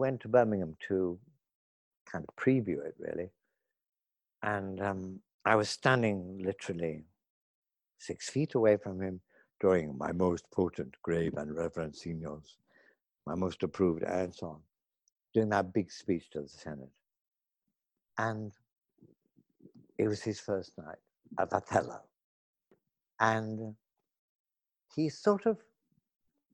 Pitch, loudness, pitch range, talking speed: 100 Hz, -33 LUFS, 85-110 Hz, 120 wpm